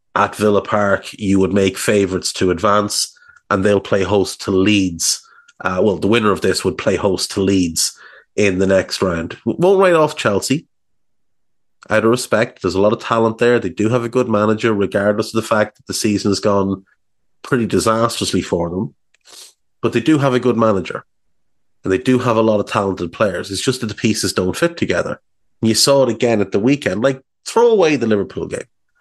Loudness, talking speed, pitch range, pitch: -16 LUFS, 205 wpm, 100-125 Hz, 110 Hz